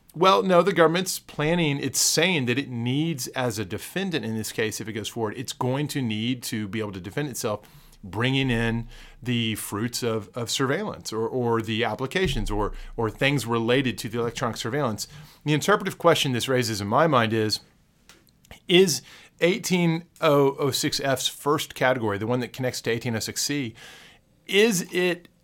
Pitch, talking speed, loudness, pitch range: 125 Hz, 165 wpm, -24 LUFS, 115-150 Hz